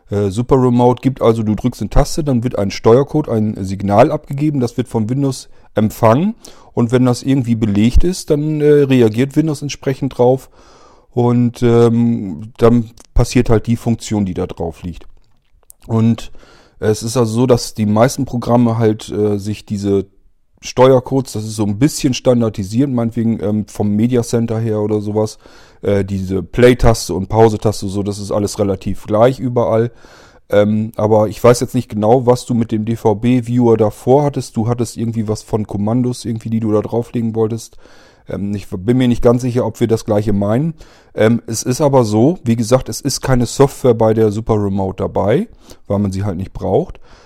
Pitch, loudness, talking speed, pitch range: 115 Hz, -15 LUFS, 180 wpm, 105-125 Hz